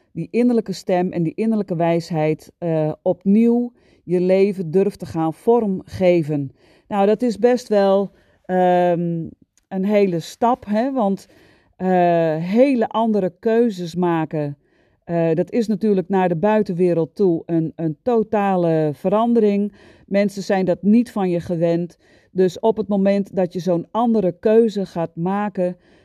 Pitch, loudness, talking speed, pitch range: 190 Hz, -19 LUFS, 140 wpm, 170-215 Hz